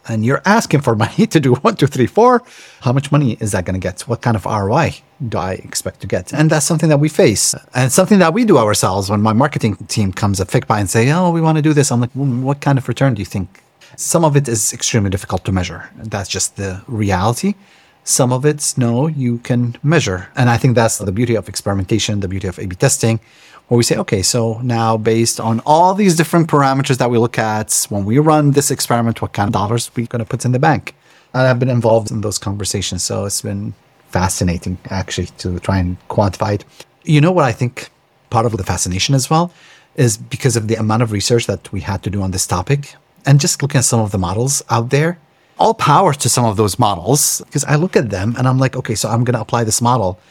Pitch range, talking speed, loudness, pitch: 105-140 Hz, 250 wpm, -15 LUFS, 120 Hz